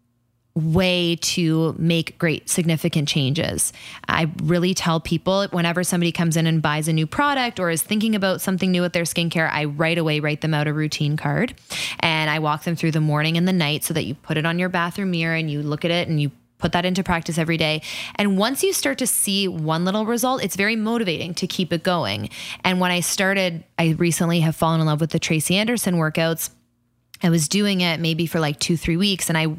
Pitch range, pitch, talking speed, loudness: 160-185 Hz, 170 Hz, 225 wpm, -21 LUFS